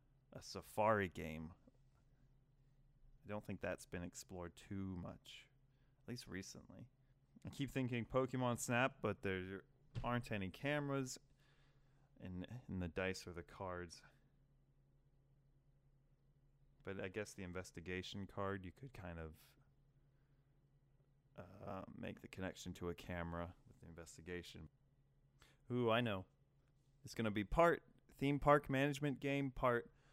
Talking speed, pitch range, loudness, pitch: 125 wpm, 95-140 Hz, -43 LUFS, 130 Hz